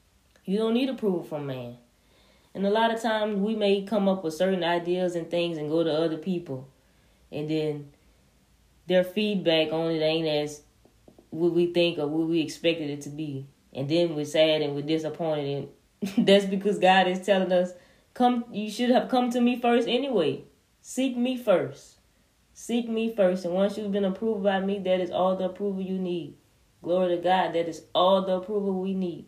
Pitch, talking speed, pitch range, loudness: 180 Hz, 195 wpm, 155-205 Hz, -26 LUFS